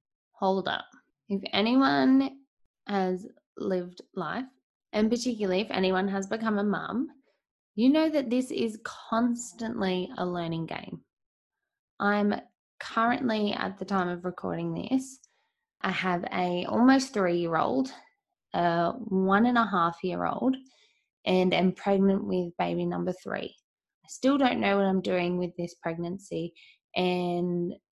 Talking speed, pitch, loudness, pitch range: 130 wpm, 195 Hz, -28 LUFS, 180-245 Hz